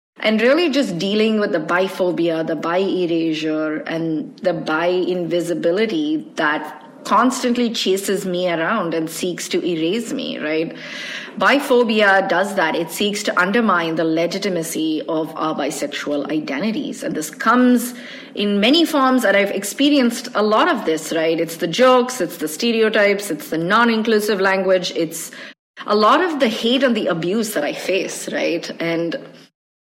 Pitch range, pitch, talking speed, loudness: 170-245 Hz, 200 Hz, 150 wpm, -18 LUFS